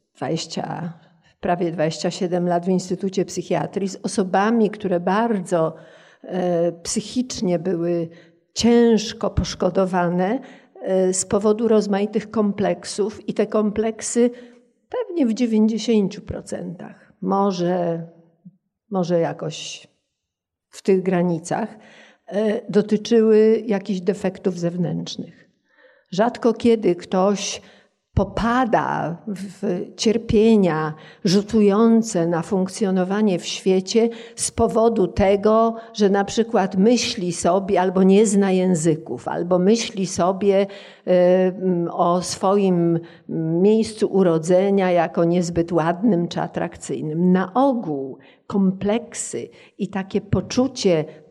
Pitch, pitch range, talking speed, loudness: 195 Hz, 175-215 Hz, 90 wpm, -20 LUFS